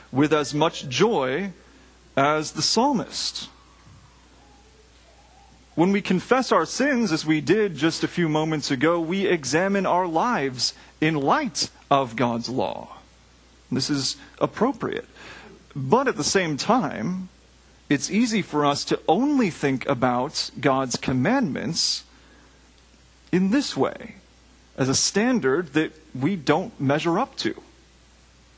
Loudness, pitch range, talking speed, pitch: -23 LUFS, 130-185 Hz, 125 wpm, 155 Hz